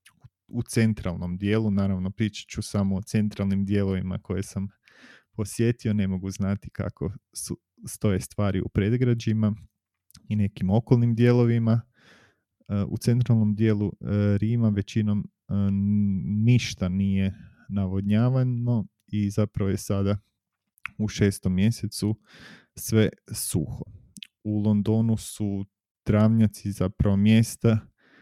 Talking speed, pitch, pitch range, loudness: 105 wpm, 105 Hz, 100-110 Hz, -25 LUFS